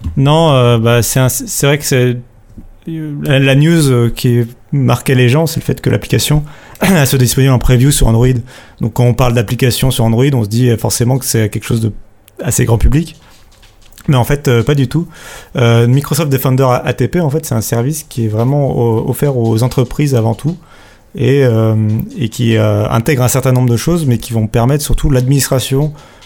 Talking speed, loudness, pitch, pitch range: 200 wpm, -12 LUFS, 125 Hz, 115-140 Hz